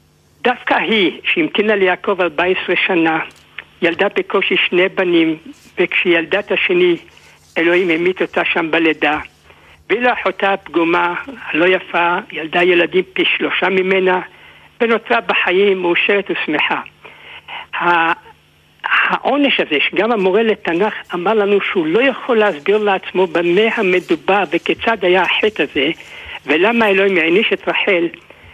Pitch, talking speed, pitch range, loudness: 190 Hz, 115 wpm, 175-215 Hz, -15 LUFS